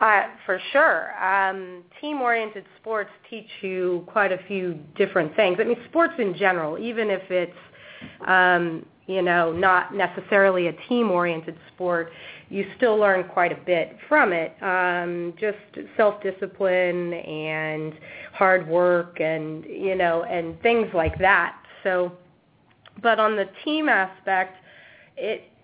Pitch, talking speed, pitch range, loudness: 185 Hz, 140 wpm, 175-205 Hz, -23 LUFS